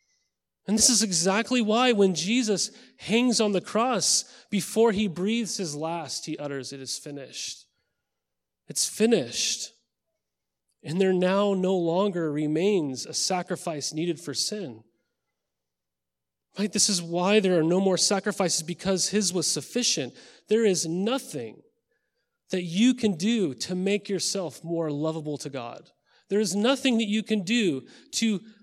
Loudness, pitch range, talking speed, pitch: -25 LUFS, 160-215 Hz, 145 wpm, 190 Hz